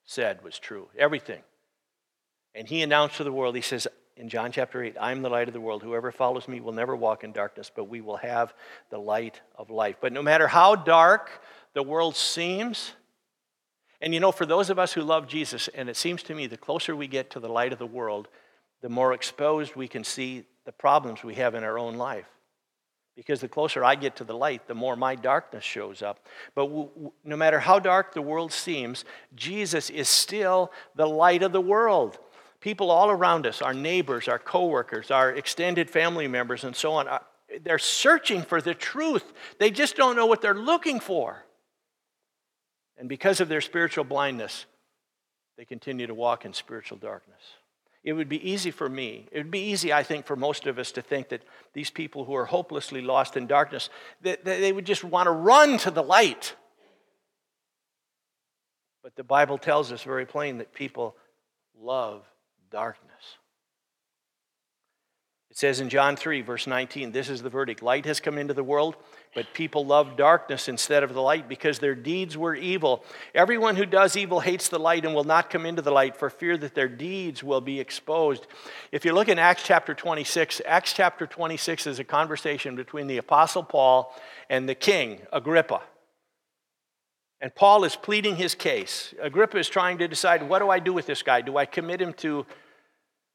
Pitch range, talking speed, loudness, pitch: 130-180 Hz, 195 wpm, -25 LUFS, 150 Hz